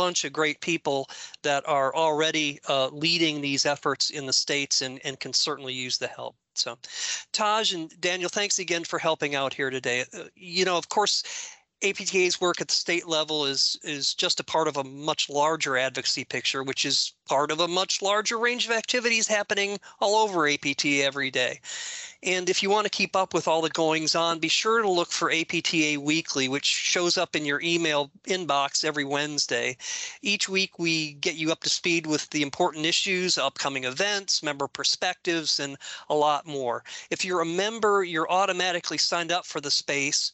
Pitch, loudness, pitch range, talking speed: 160 Hz, -25 LUFS, 145-185 Hz, 190 wpm